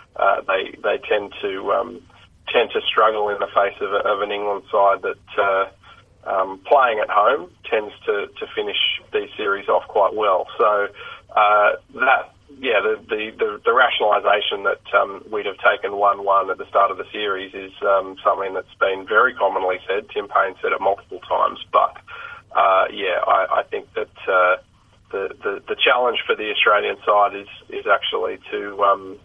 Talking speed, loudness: 185 wpm, -20 LUFS